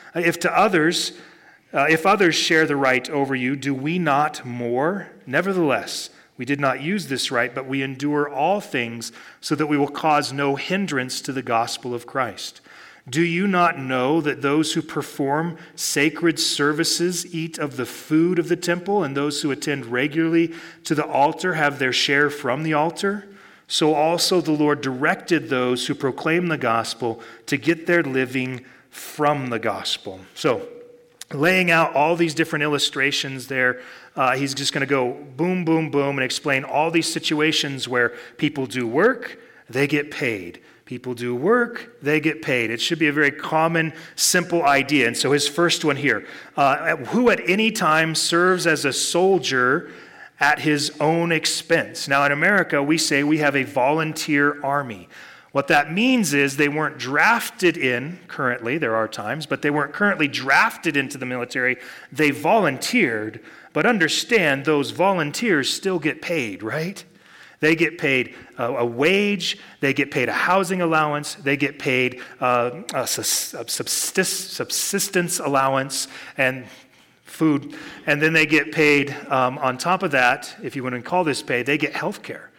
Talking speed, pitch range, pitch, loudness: 165 wpm, 135-165 Hz, 150 Hz, -21 LUFS